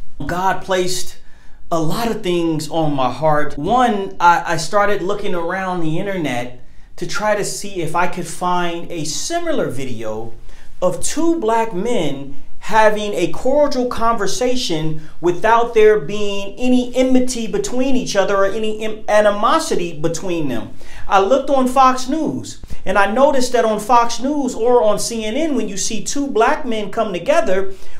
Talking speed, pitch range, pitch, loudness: 155 wpm, 170-235 Hz, 200 Hz, -18 LUFS